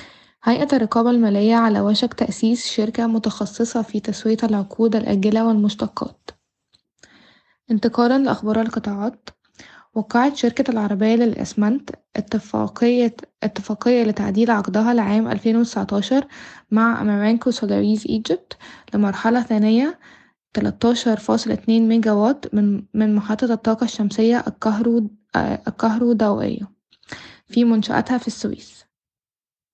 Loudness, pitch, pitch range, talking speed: -19 LUFS, 225 Hz, 215-235 Hz, 95 wpm